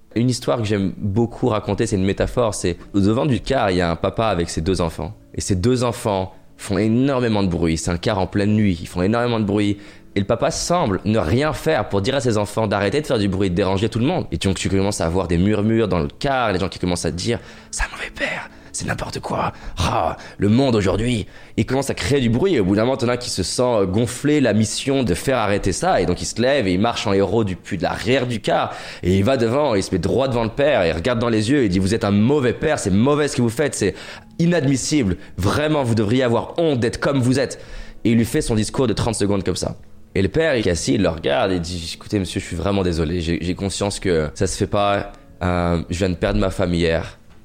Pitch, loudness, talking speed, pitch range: 105 Hz, -20 LUFS, 275 wpm, 95-120 Hz